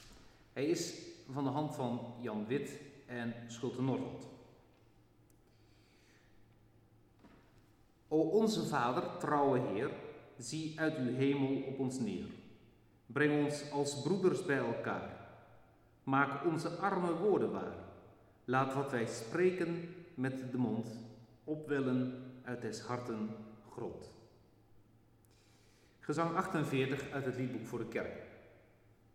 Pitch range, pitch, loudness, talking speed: 115-145 Hz, 125 Hz, -37 LUFS, 110 wpm